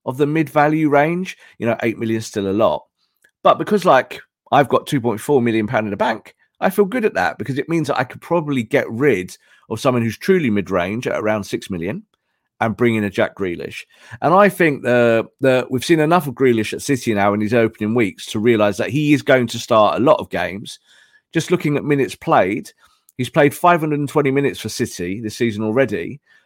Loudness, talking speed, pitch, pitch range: -18 LUFS, 215 wpm, 130 Hz, 110-150 Hz